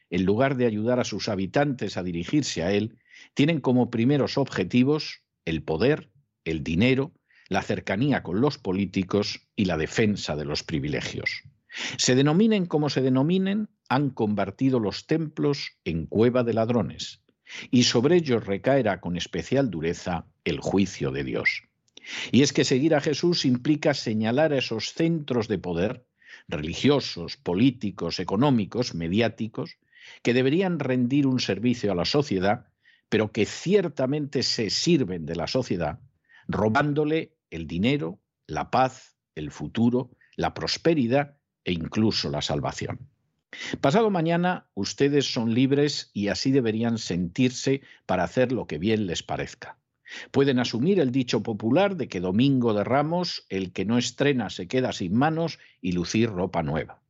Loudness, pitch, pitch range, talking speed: -25 LUFS, 125 Hz, 100-140 Hz, 145 wpm